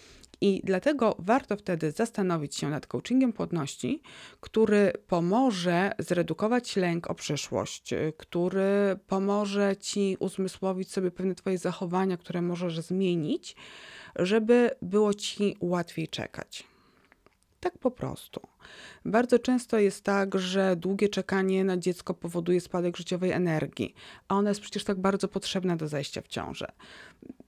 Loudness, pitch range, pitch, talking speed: -28 LUFS, 180-205 Hz, 190 Hz, 125 wpm